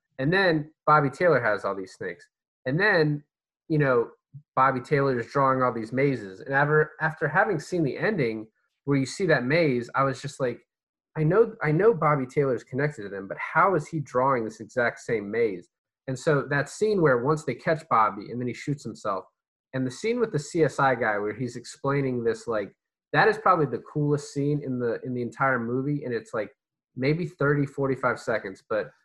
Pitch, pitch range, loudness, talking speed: 140 Hz, 125-155 Hz, -25 LUFS, 205 wpm